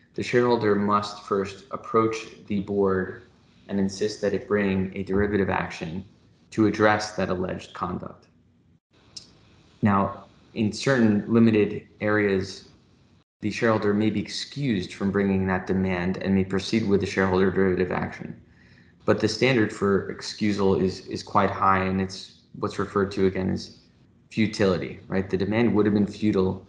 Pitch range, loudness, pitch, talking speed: 95-105 Hz, -25 LUFS, 100 Hz, 150 wpm